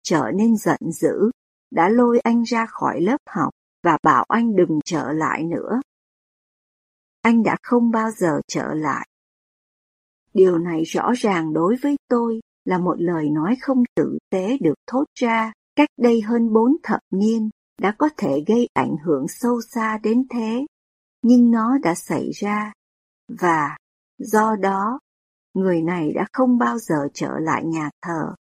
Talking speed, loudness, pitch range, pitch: 160 wpm, -20 LUFS, 180-240 Hz, 220 Hz